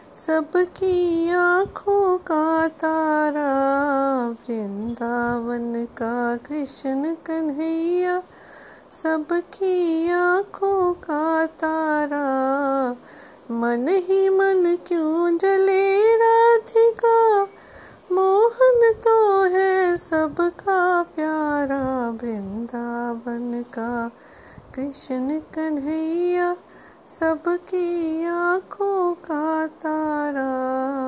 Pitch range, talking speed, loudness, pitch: 270-360 Hz, 60 wpm, -21 LUFS, 320 Hz